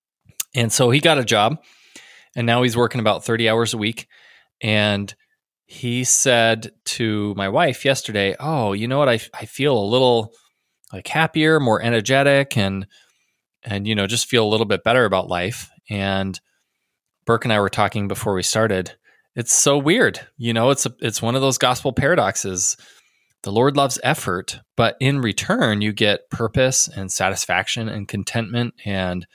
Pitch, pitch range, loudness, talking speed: 115 Hz, 105-130 Hz, -19 LUFS, 170 wpm